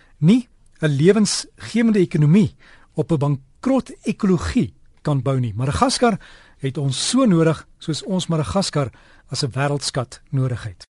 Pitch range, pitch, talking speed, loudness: 135-200 Hz, 155 Hz, 140 wpm, -20 LUFS